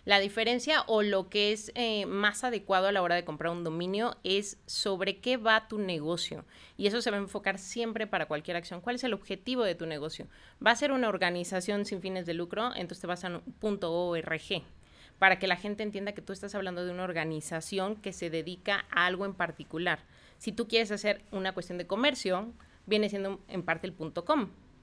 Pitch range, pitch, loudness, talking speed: 175-215 Hz, 195 Hz, -31 LUFS, 210 wpm